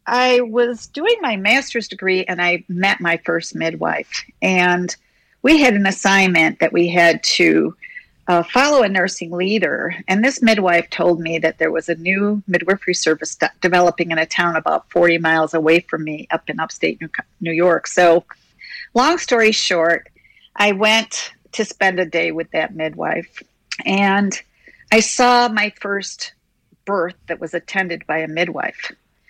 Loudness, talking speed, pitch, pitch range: -17 LUFS, 165 wpm, 185 Hz, 170-215 Hz